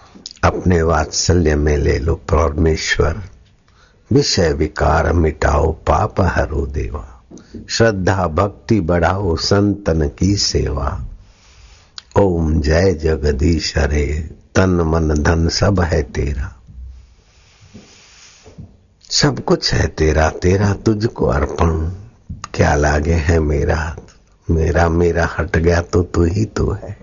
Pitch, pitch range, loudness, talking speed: 85 Hz, 80-95 Hz, -16 LUFS, 105 wpm